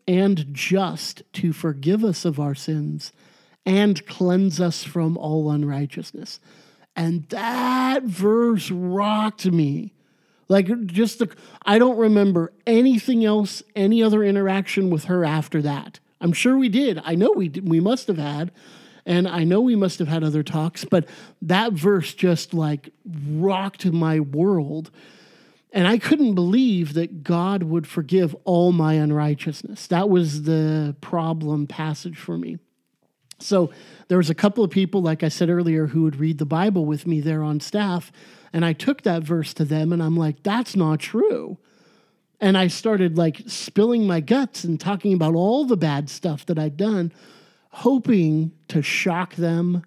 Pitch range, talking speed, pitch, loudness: 160-205 Hz, 165 wpm, 175 Hz, -21 LUFS